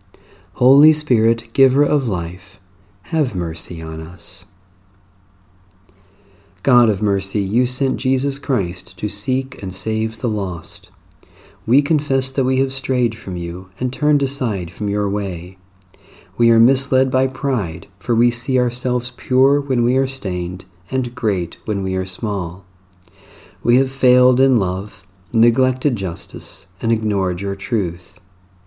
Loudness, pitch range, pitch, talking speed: -18 LUFS, 90-130 Hz, 105 Hz, 140 wpm